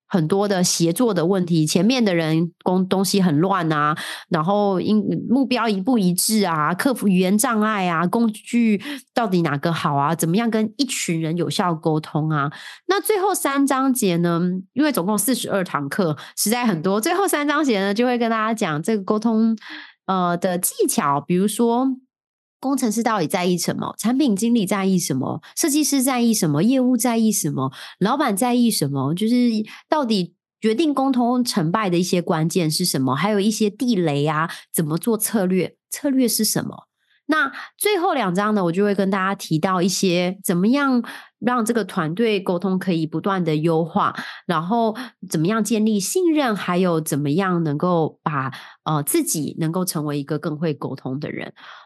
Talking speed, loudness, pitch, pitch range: 270 characters per minute, -20 LUFS, 200 Hz, 175-235 Hz